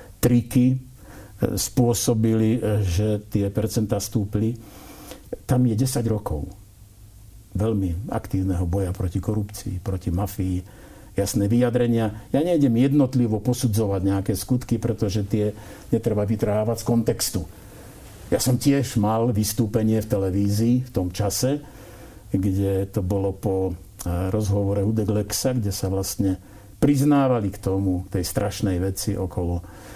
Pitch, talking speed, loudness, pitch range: 105 Hz, 115 wpm, -23 LUFS, 100-115 Hz